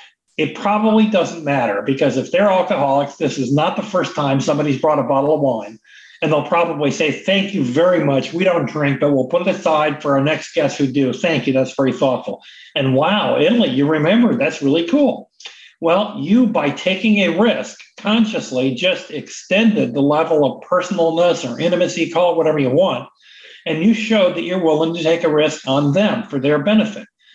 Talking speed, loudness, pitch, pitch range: 195 wpm, -17 LUFS, 165 Hz, 140-195 Hz